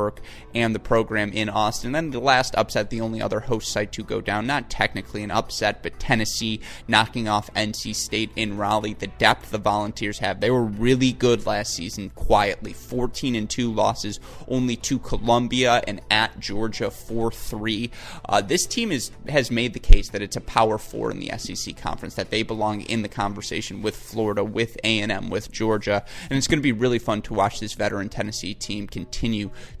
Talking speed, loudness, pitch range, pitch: 195 wpm, -24 LUFS, 105-120 Hz, 110 Hz